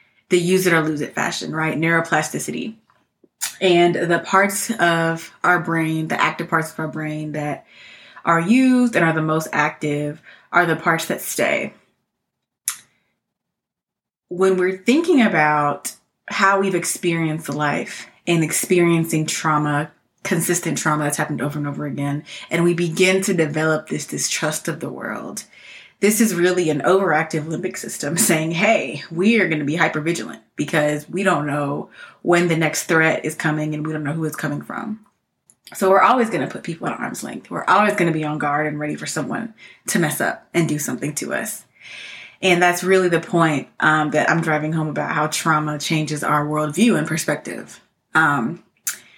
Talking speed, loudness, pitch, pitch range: 175 wpm, -19 LUFS, 165 Hz, 150-185 Hz